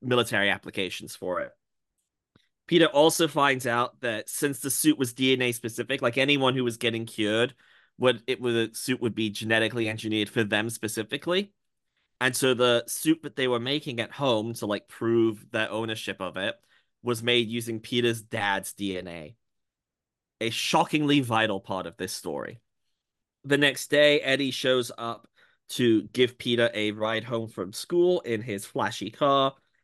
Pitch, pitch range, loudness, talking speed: 120 Hz, 110-135 Hz, -26 LUFS, 165 wpm